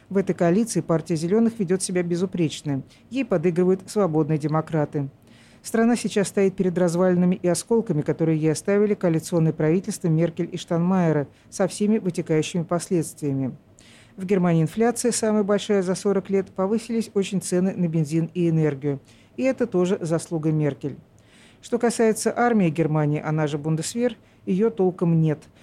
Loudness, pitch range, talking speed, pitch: -23 LUFS, 155-200 Hz, 145 wpm, 175 Hz